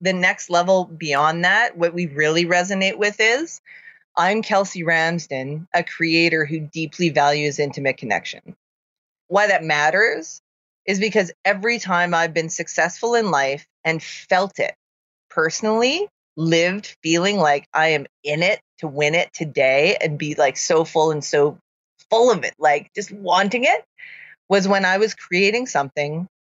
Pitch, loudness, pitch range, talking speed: 170 Hz, -19 LUFS, 155-200 Hz, 155 wpm